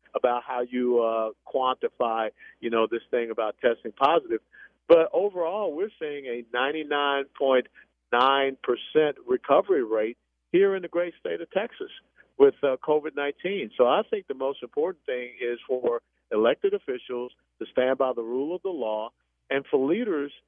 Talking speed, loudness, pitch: 155 wpm, -26 LUFS, 145 Hz